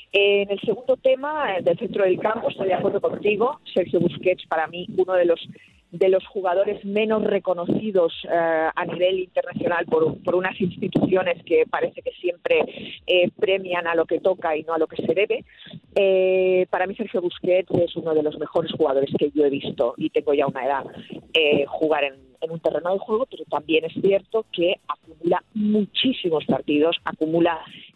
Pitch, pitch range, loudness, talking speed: 185 Hz, 165-205 Hz, -22 LUFS, 185 wpm